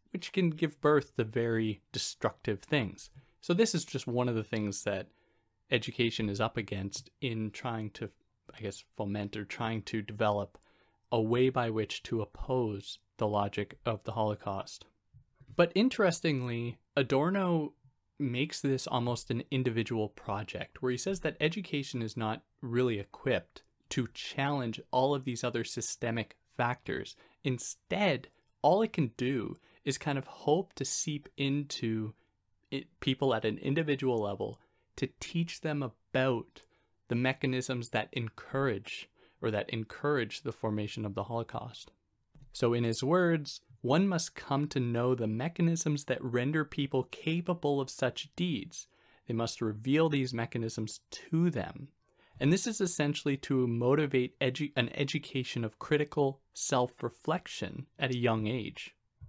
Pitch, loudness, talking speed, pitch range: 125 Hz, -33 LUFS, 145 wpm, 115-145 Hz